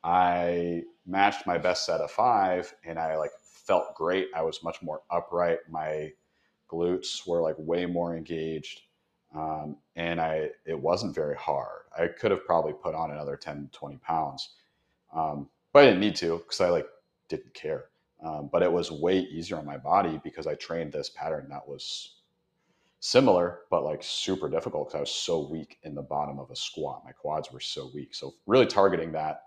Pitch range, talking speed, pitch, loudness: 80-115 Hz, 190 wpm, 85 Hz, -28 LUFS